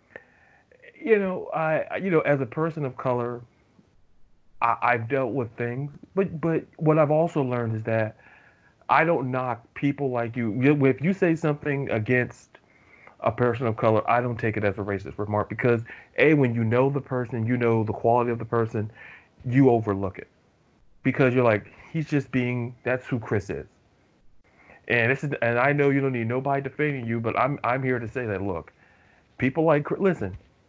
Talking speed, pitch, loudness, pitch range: 190 wpm, 125 Hz, -25 LUFS, 115-140 Hz